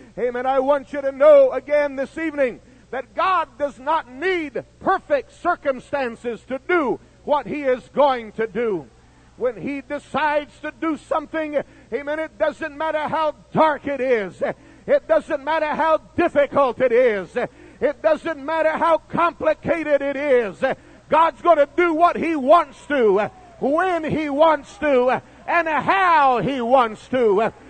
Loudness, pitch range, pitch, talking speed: -20 LUFS, 270-320 Hz, 295 Hz, 150 wpm